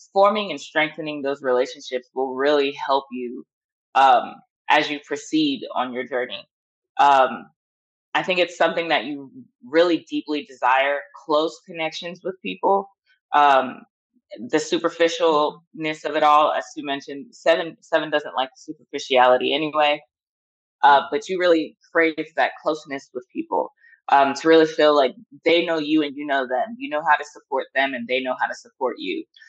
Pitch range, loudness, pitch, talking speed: 140-170 Hz, -21 LUFS, 150 Hz, 160 wpm